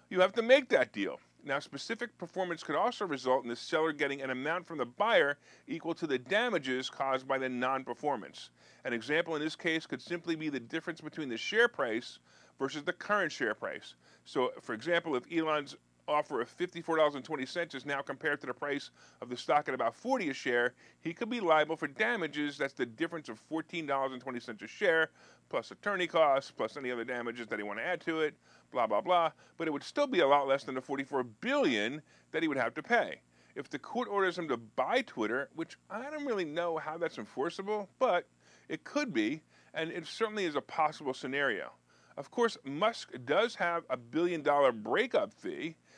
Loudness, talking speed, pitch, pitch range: -33 LUFS, 215 wpm, 155 Hz, 135-175 Hz